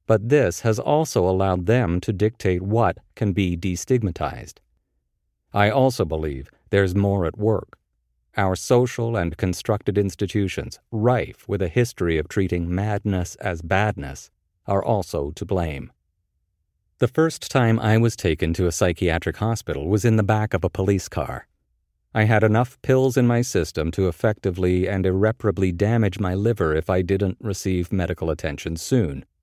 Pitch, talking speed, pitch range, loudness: 95 Hz, 155 wpm, 85-110 Hz, -22 LUFS